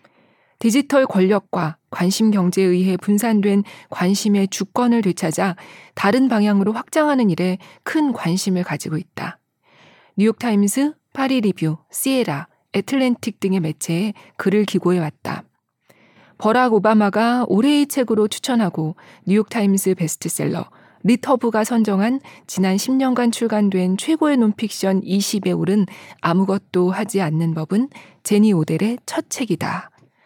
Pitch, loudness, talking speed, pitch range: 205 Hz, -19 LUFS, 280 characters per minute, 185-235 Hz